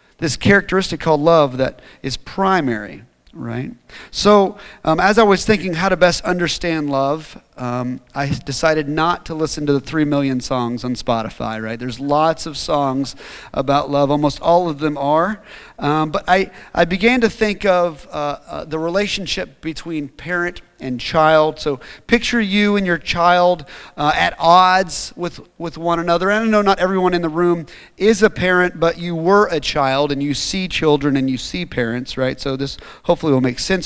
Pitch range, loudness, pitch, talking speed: 140-185 Hz, -17 LUFS, 160 Hz, 185 wpm